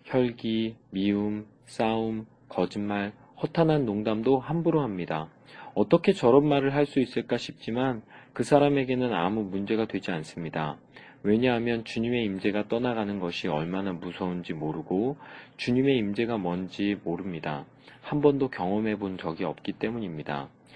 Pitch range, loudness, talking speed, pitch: 95-130 Hz, -28 LUFS, 310 characters per minute, 110 Hz